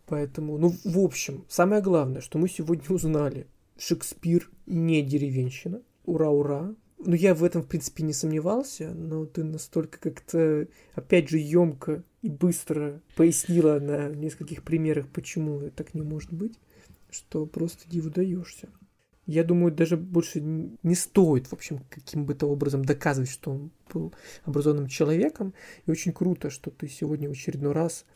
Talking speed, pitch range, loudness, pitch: 155 wpm, 150-175 Hz, -27 LUFS, 160 Hz